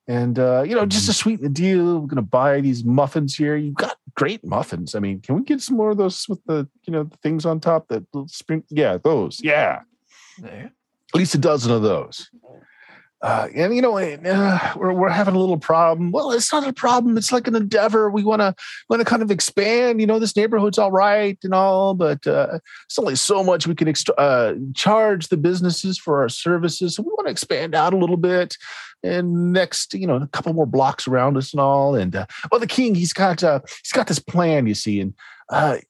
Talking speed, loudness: 225 wpm, -19 LUFS